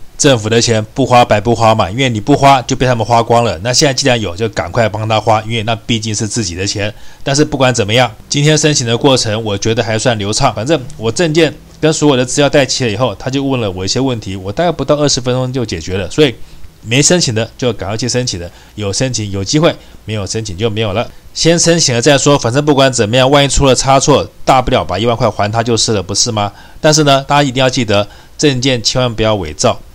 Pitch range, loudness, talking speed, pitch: 110-135 Hz, -12 LUFS, 365 characters per minute, 120 Hz